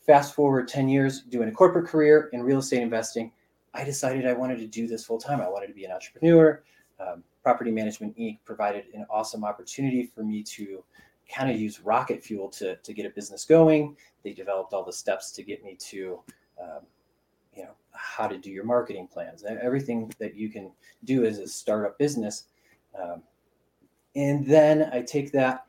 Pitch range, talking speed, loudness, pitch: 110-140 Hz, 190 wpm, -25 LUFS, 125 Hz